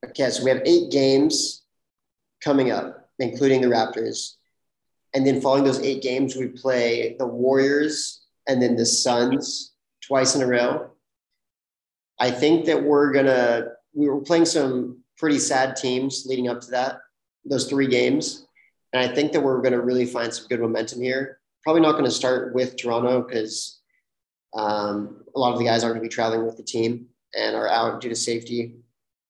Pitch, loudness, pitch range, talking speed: 125 Hz, -22 LUFS, 120-135 Hz, 185 wpm